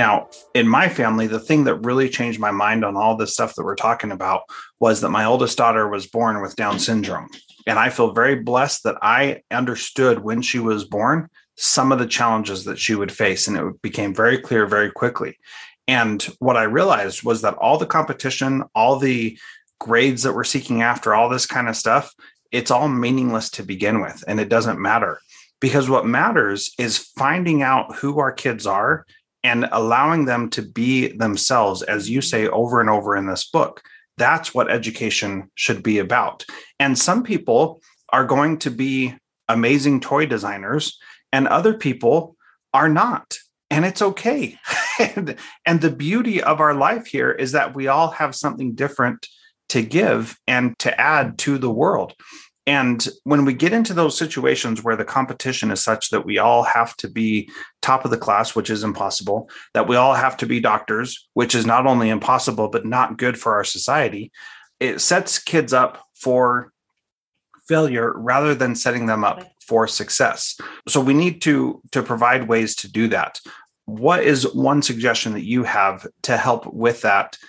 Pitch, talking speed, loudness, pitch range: 125 Hz, 180 wpm, -19 LUFS, 110-140 Hz